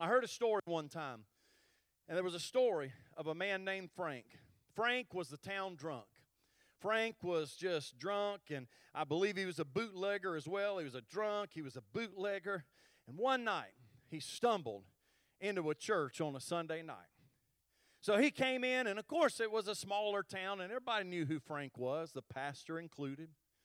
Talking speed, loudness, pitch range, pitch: 190 wpm, -40 LUFS, 150-205 Hz, 180 Hz